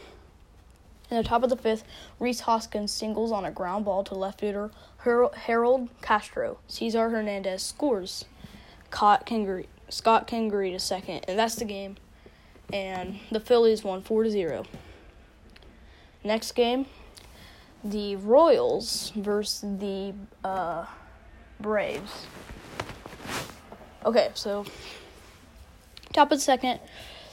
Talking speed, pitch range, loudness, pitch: 110 wpm, 200-235 Hz, -27 LUFS, 215 Hz